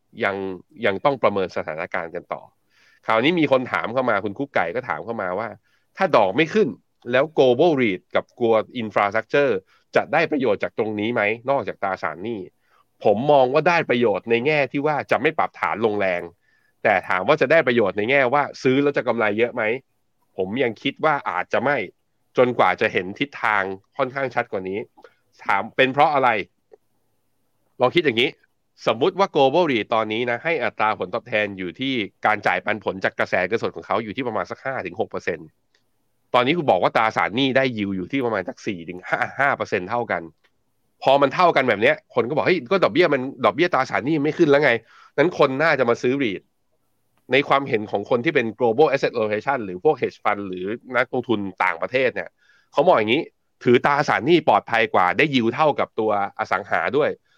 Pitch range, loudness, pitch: 105-135 Hz, -21 LUFS, 120 Hz